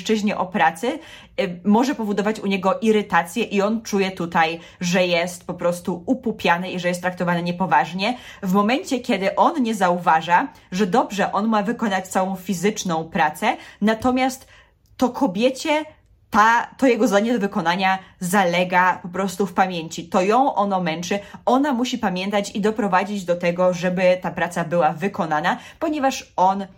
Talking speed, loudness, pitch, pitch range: 150 wpm, -21 LUFS, 195 Hz, 180-225 Hz